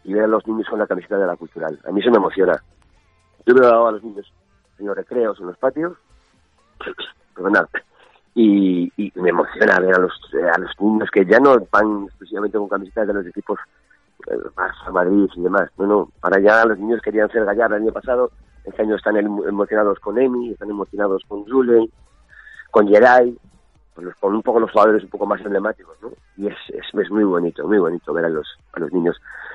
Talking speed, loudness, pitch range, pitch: 210 wpm, -18 LUFS, 95-110 Hz, 105 Hz